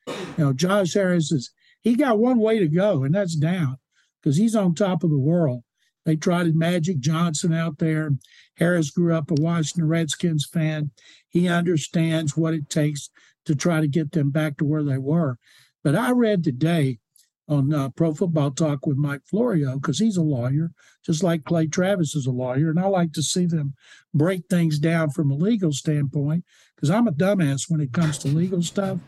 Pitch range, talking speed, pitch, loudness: 150-175 Hz, 195 wpm, 160 Hz, -22 LUFS